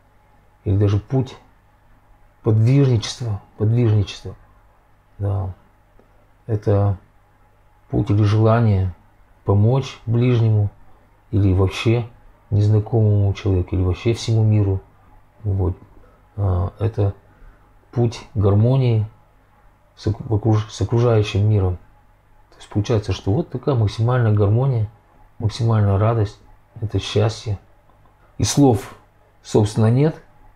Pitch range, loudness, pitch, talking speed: 100-115 Hz, -20 LUFS, 105 Hz, 90 wpm